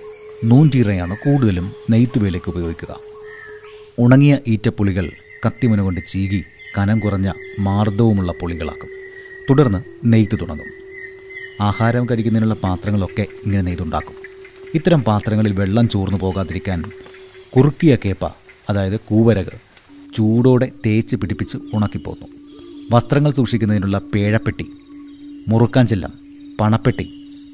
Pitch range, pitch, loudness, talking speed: 100-150 Hz, 115 Hz, -17 LUFS, 85 wpm